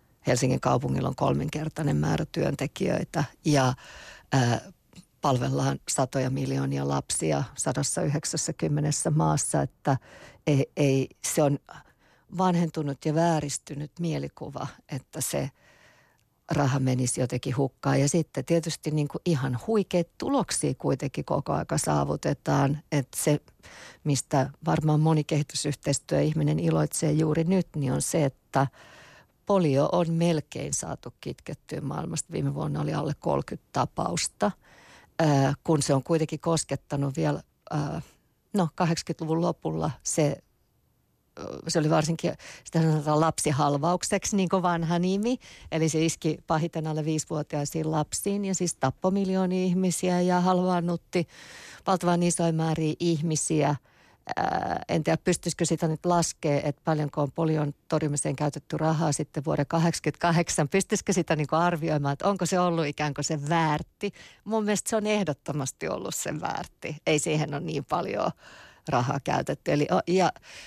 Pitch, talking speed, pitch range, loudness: 155 Hz, 130 wpm, 145-170 Hz, -27 LUFS